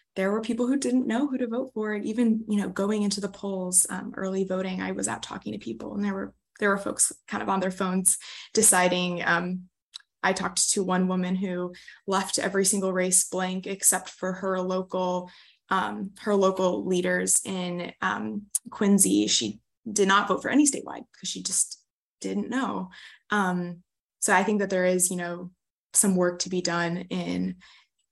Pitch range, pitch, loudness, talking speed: 180-205 Hz, 185 Hz, -25 LUFS, 190 wpm